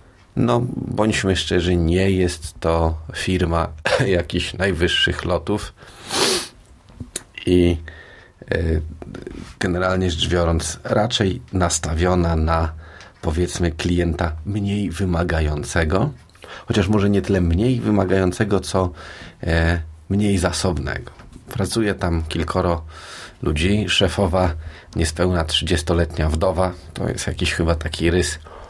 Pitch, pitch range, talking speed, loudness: 90 Hz, 85-95 Hz, 95 wpm, -20 LUFS